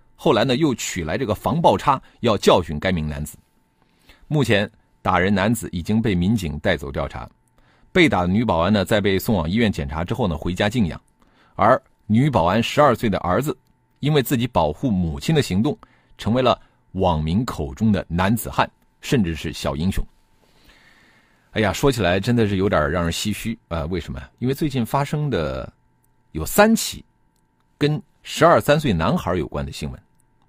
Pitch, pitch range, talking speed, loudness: 100 Hz, 80-120 Hz, 265 characters per minute, -21 LUFS